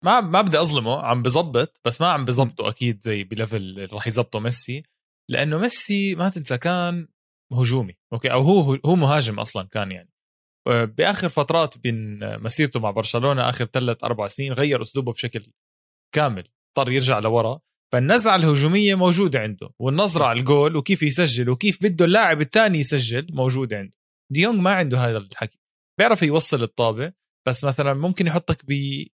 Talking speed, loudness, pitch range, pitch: 155 wpm, -20 LUFS, 115-165 Hz, 135 Hz